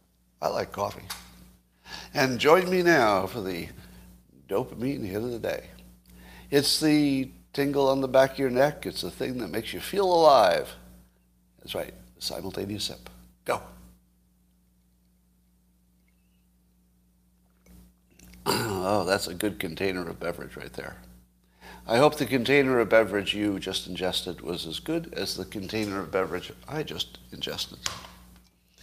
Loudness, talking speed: -26 LUFS, 135 wpm